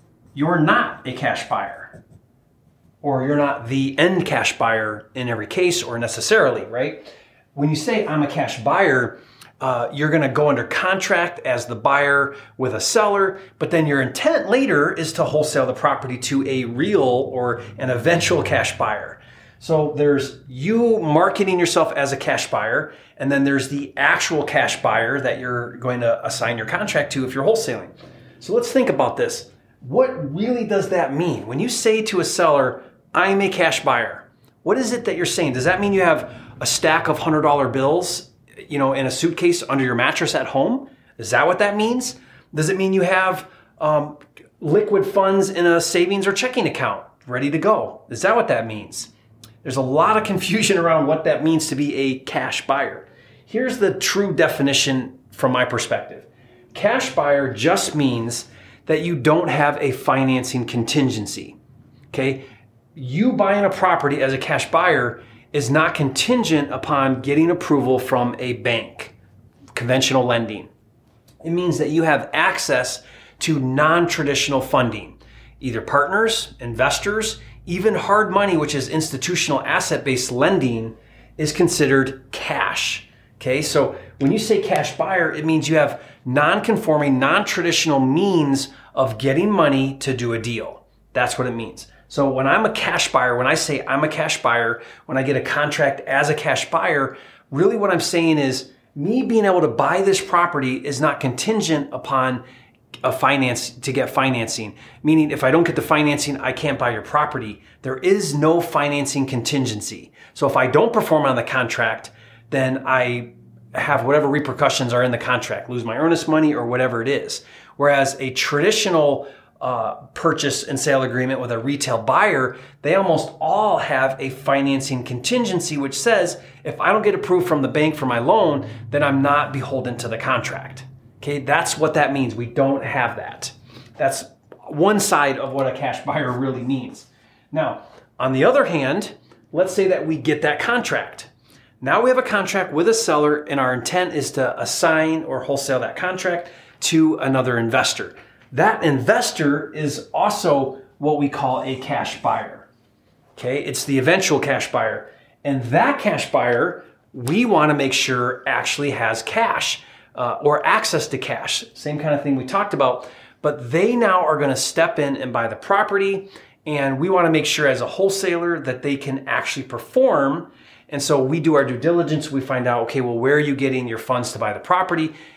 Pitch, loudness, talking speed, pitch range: 140 Hz, -19 LUFS, 180 wpm, 130-170 Hz